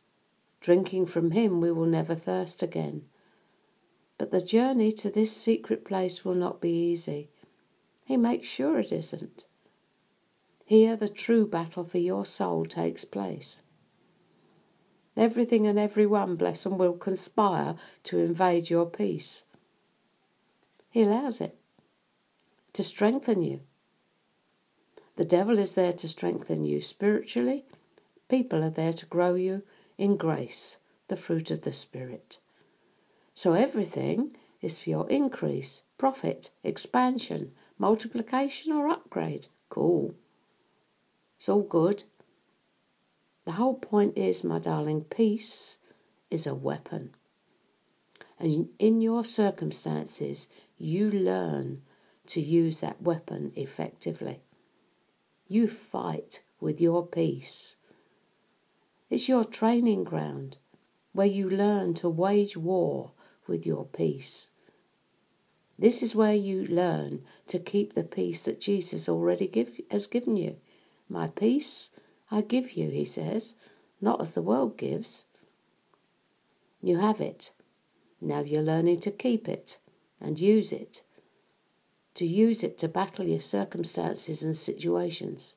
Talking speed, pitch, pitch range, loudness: 120 wpm, 185 Hz, 165-215 Hz, -28 LUFS